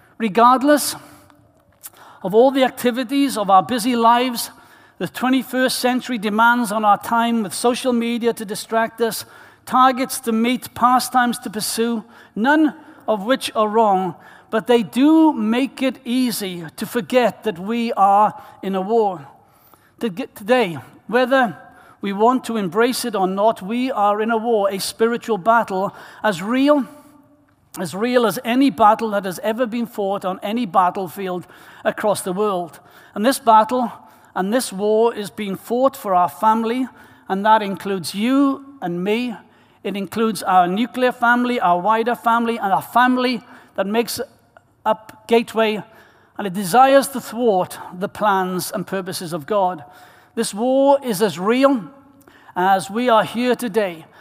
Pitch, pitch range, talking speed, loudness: 230 Hz, 200-250 Hz, 150 wpm, -19 LUFS